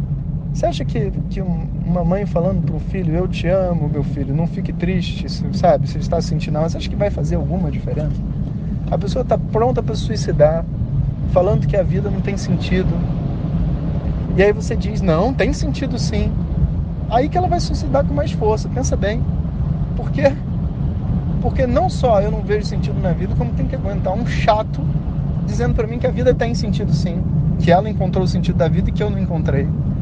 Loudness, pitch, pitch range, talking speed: -19 LUFS, 160 Hz, 150-175 Hz, 200 wpm